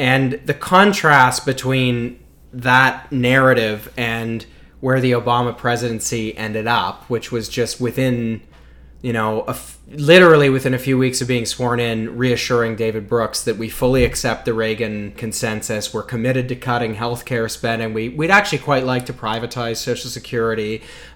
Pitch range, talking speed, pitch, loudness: 115-130 Hz, 160 wpm, 120 Hz, -18 LUFS